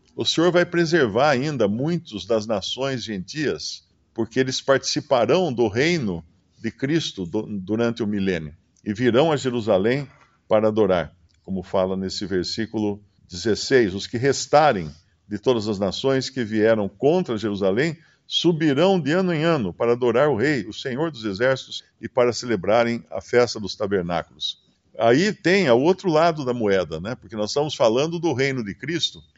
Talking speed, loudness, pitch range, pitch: 160 wpm, -22 LUFS, 100-145 Hz, 115 Hz